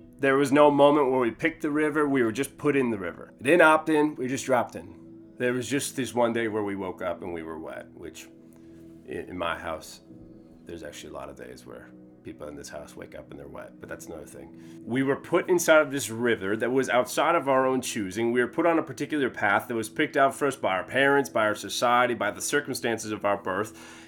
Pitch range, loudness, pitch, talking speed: 95-140 Hz, -25 LUFS, 120 Hz, 250 wpm